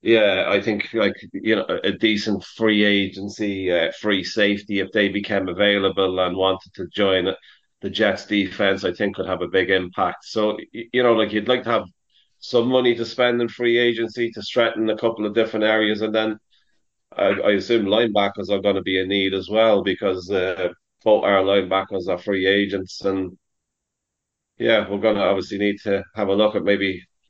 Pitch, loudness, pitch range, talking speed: 100 Hz, -21 LUFS, 95-110 Hz, 195 wpm